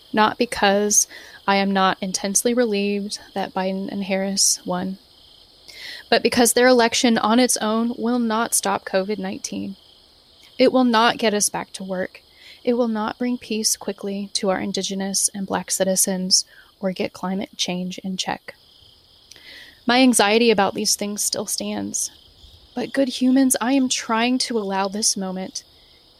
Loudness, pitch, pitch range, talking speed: -20 LUFS, 205 Hz, 190-235 Hz, 155 wpm